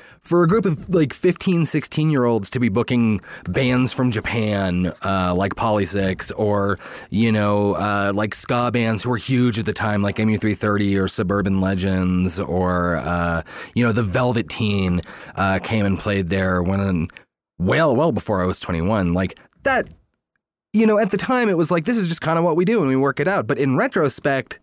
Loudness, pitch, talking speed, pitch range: -20 LUFS, 110 Hz, 200 wpm, 95-130 Hz